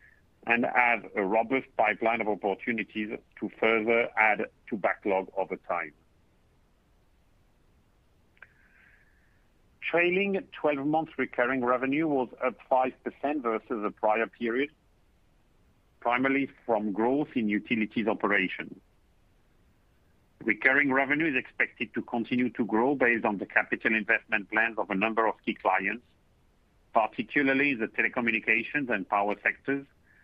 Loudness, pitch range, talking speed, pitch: -28 LUFS, 100-135 Hz, 115 wpm, 115 Hz